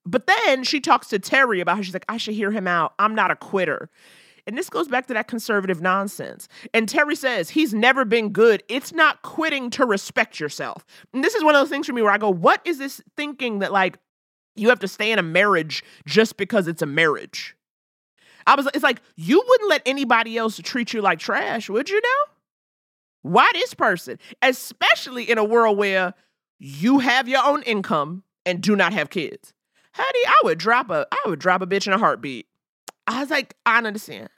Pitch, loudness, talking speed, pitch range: 230 Hz, -20 LUFS, 215 wpm, 195-275 Hz